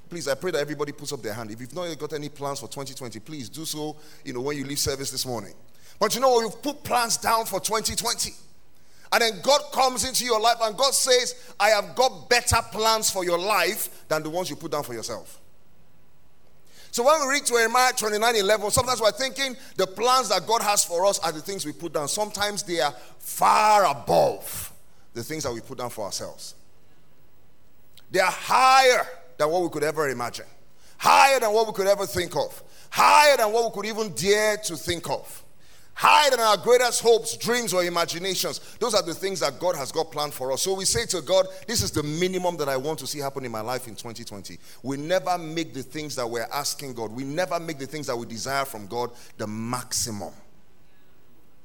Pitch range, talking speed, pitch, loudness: 135-220 Hz, 215 wpm, 170 Hz, -23 LUFS